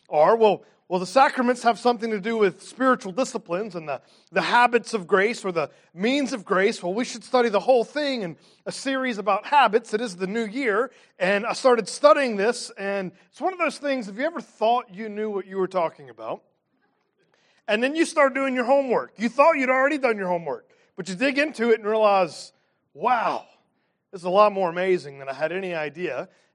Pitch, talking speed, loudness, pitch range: 225 Hz, 215 wpm, -23 LUFS, 190-260 Hz